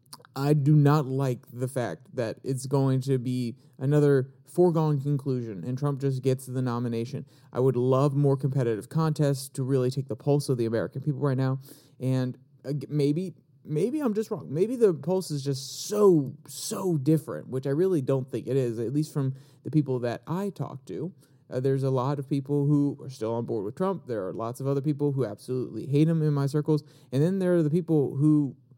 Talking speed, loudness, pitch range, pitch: 210 wpm, -27 LUFS, 130-150 Hz, 140 Hz